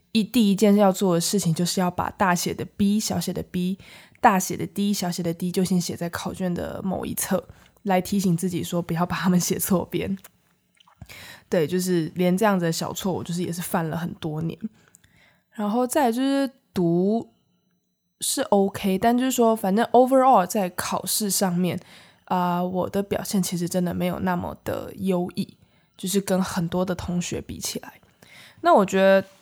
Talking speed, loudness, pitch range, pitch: 270 characters per minute, -23 LUFS, 180-205 Hz, 185 Hz